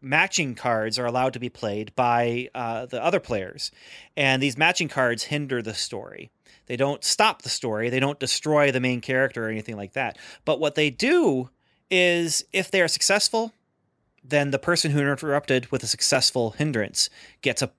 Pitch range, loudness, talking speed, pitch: 125-150 Hz, -23 LUFS, 180 wpm, 135 Hz